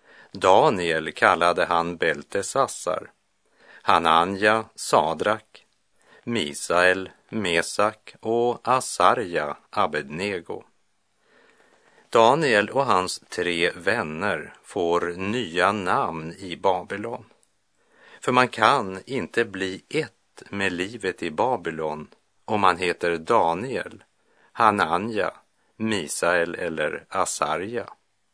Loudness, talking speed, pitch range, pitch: -23 LUFS, 85 wpm, 85-110 Hz, 95 Hz